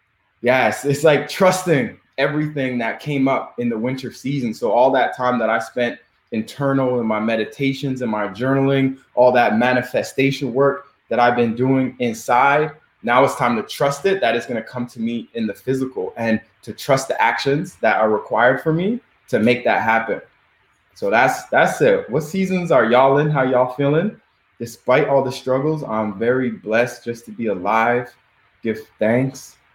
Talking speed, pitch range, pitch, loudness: 180 wpm, 120-140 Hz, 130 Hz, -19 LUFS